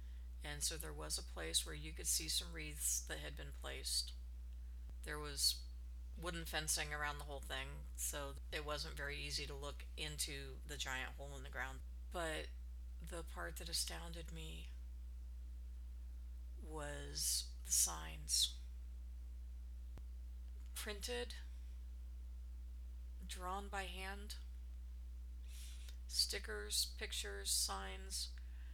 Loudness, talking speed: -44 LUFS, 115 wpm